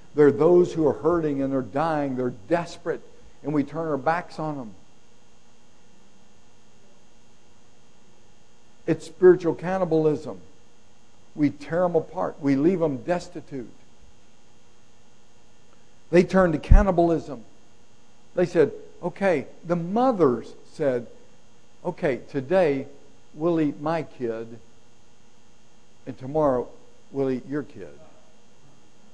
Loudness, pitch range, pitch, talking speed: -24 LUFS, 120-170 Hz, 145 Hz, 105 wpm